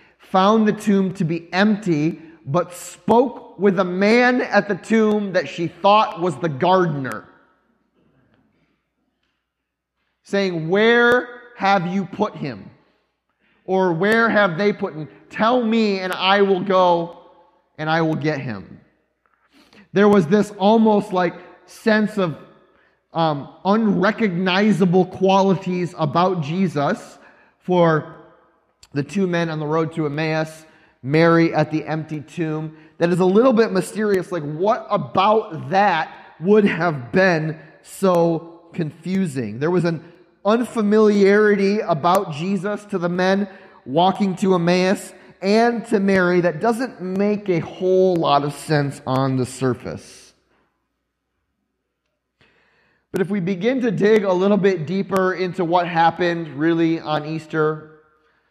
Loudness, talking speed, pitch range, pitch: -19 LUFS, 130 wpm, 160-200 Hz, 180 Hz